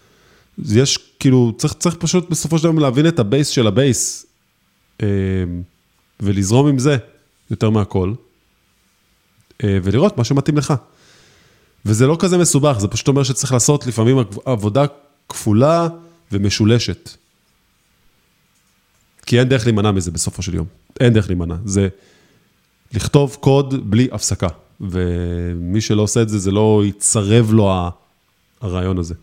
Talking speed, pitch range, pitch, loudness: 125 wpm, 95-140 Hz, 110 Hz, -16 LUFS